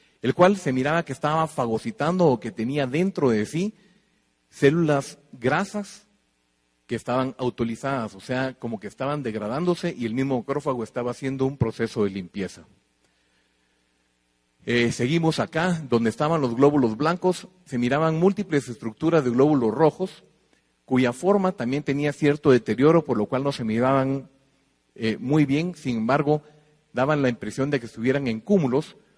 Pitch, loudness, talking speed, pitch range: 135 Hz, -24 LUFS, 150 wpm, 115-160 Hz